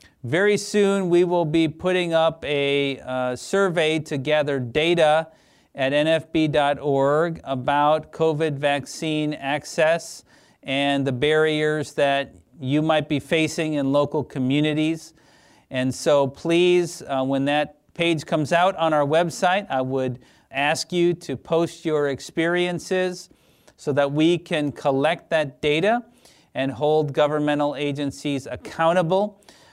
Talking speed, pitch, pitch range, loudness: 125 wpm, 150 Hz, 140-165 Hz, -22 LUFS